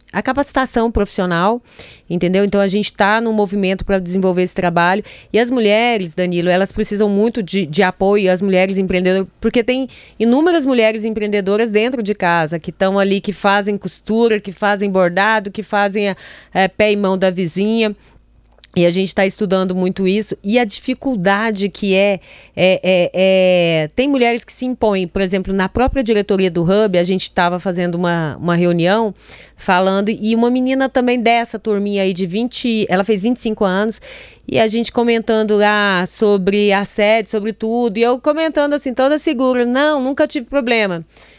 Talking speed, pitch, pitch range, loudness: 175 wpm, 205 Hz, 190-230 Hz, -16 LUFS